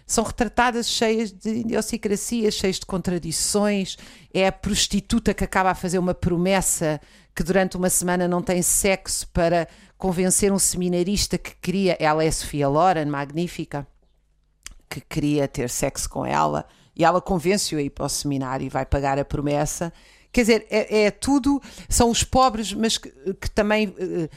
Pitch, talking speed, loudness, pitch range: 185 Hz, 165 wpm, -22 LUFS, 155-210 Hz